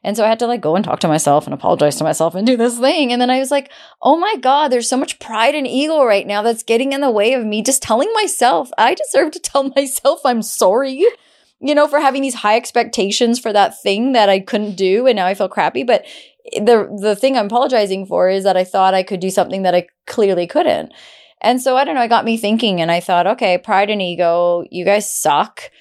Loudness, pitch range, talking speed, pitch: -15 LUFS, 195-265 Hz, 255 wpm, 230 Hz